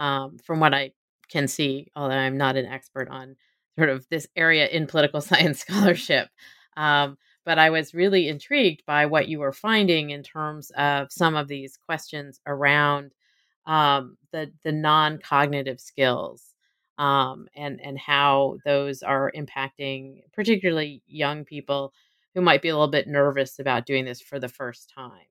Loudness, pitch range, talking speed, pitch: -23 LUFS, 135-160 Hz, 160 wpm, 145 Hz